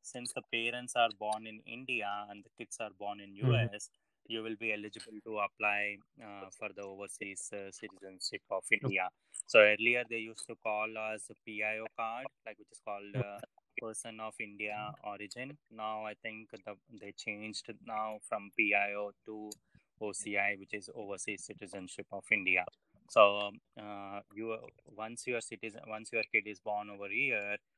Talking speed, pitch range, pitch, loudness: 170 wpm, 100-110 Hz, 105 Hz, -35 LUFS